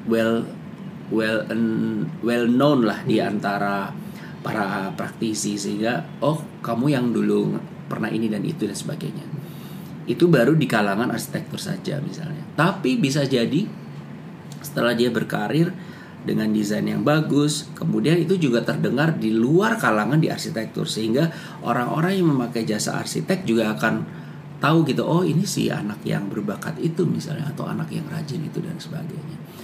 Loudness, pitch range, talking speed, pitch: -22 LUFS, 115-170 Hz, 145 wpm, 145 Hz